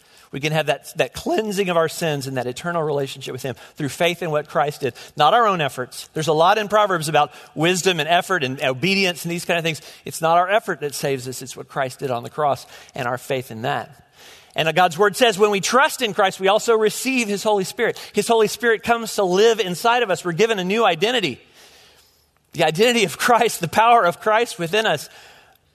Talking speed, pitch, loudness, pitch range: 230 wpm, 175 Hz, -19 LUFS, 145-215 Hz